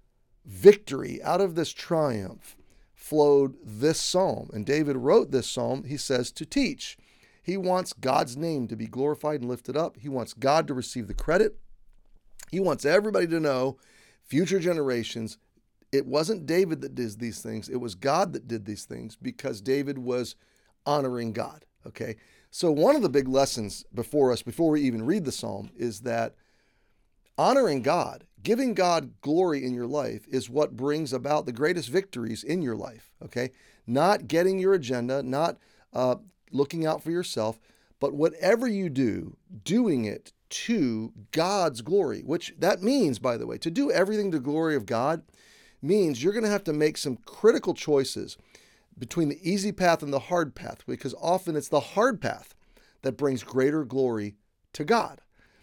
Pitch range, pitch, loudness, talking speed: 125-165 Hz, 140 Hz, -27 LUFS, 170 wpm